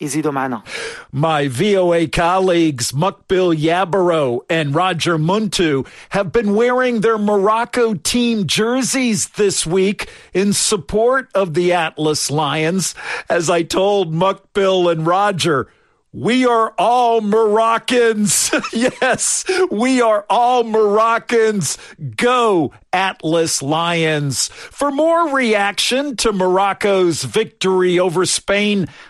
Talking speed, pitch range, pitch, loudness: 100 wpm, 170-225 Hz, 195 Hz, -16 LUFS